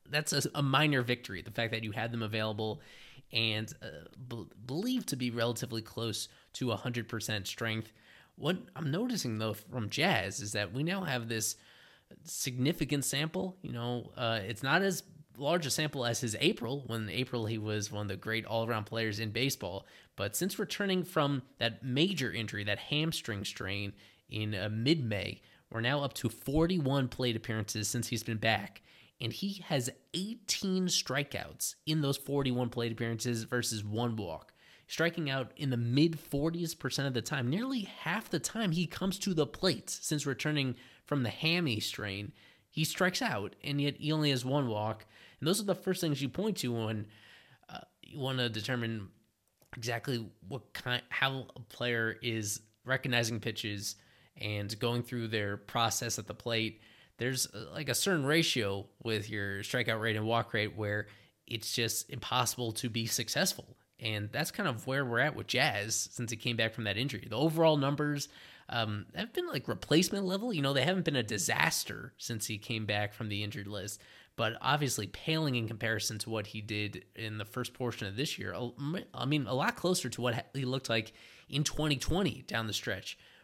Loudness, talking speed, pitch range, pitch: -34 LUFS, 185 wpm, 110-145 Hz, 120 Hz